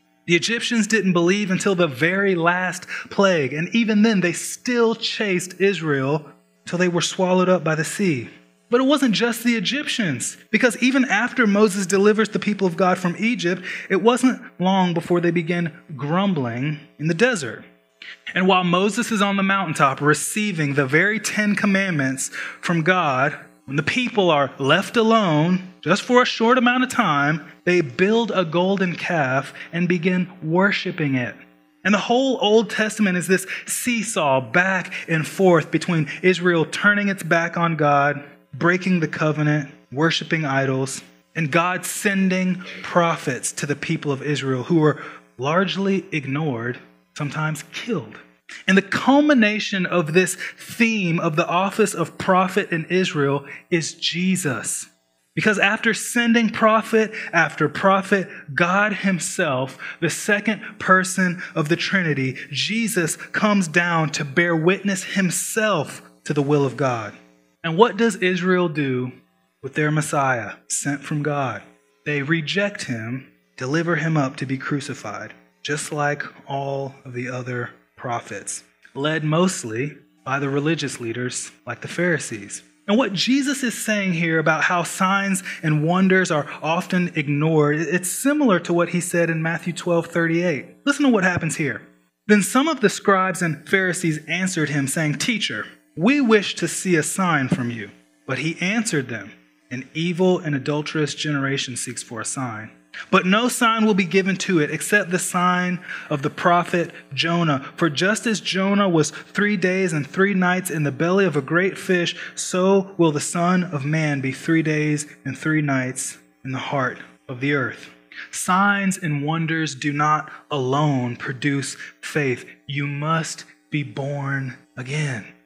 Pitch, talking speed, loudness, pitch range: 170 Hz, 155 wpm, -20 LUFS, 145-195 Hz